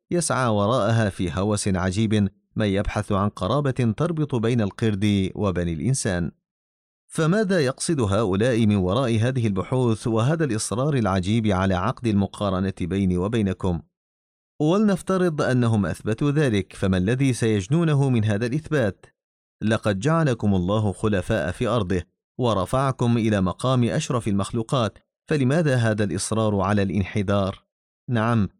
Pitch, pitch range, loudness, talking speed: 110 Hz, 95-130 Hz, -23 LUFS, 120 wpm